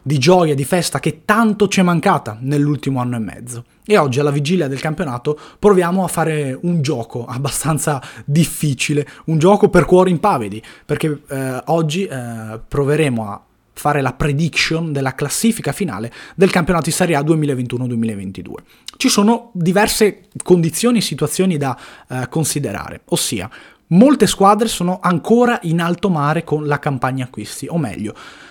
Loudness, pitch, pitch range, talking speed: -16 LUFS, 155 Hz, 135-185 Hz, 150 wpm